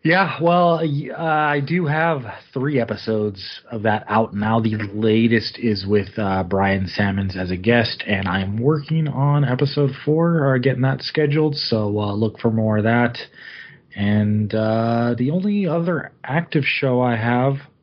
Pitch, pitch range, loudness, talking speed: 120 Hz, 105-150 Hz, -20 LUFS, 160 wpm